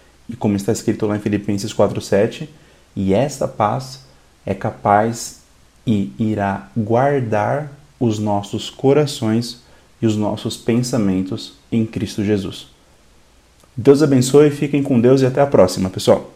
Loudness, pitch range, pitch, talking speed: -18 LUFS, 105-130 Hz, 115 Hz, 130 wpm